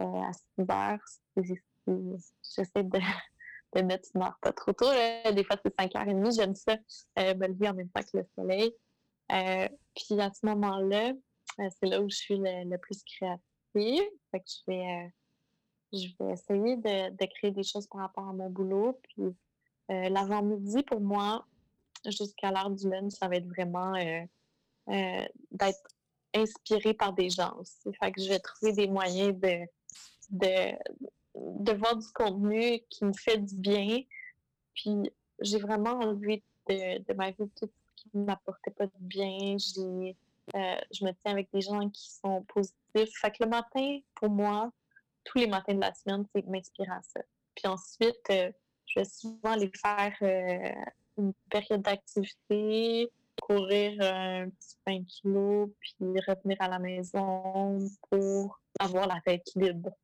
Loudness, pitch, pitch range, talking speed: -32 LUFS, 195 Hz, 190-210 Hz, 170 wpm